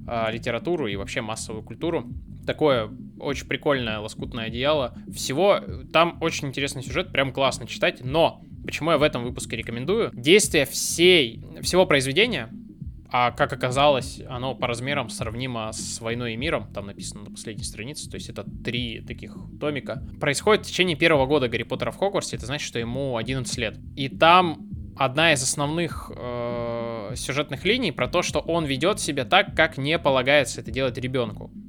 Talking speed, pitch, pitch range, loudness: 165 wpm, 130 Hz, 115-150 Hz, -23 LUFS